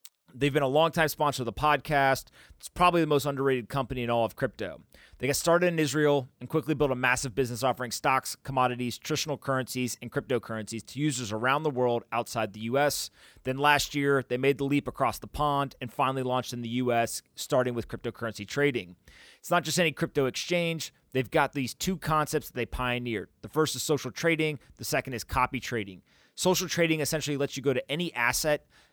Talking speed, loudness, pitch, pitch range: 200 wpm, -28 LUFS, 135 Hz, 120-150 Hz